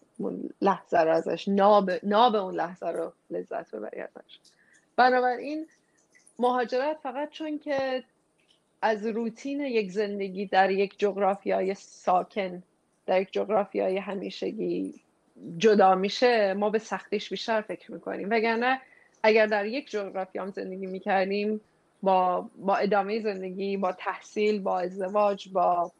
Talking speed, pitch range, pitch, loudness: 130 wpm, 190-235 Hz, 205 Hz, -27 LUFS